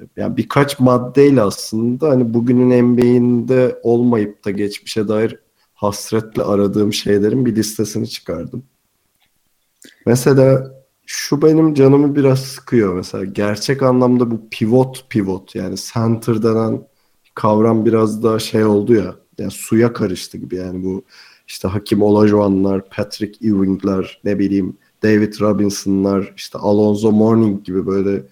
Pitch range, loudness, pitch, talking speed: 100-125 Hz, -16 LUFS, 110 Hz, 125 wpm